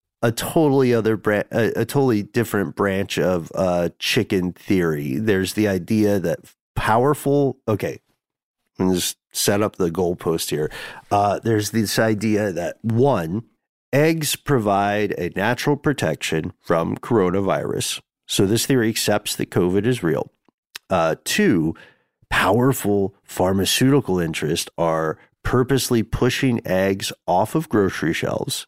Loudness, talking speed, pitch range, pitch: -21 LUFS, 125 wpm, 95-125 Hz, 105 Hz